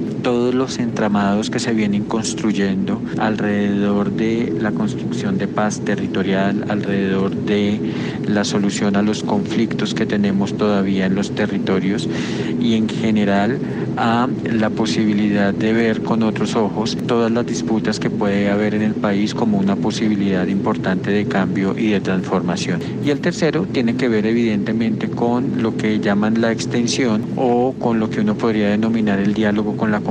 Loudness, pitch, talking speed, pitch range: -18 LUFS, 105 Hz, 160 wpm, 100-115 Hz